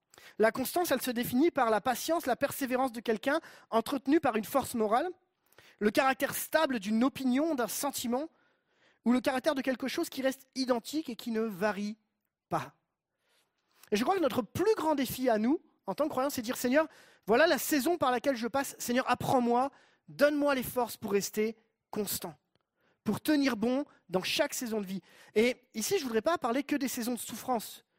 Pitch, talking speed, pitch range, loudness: 255 Hz, 195 wpm, 230-285 Hz, -31 LUFS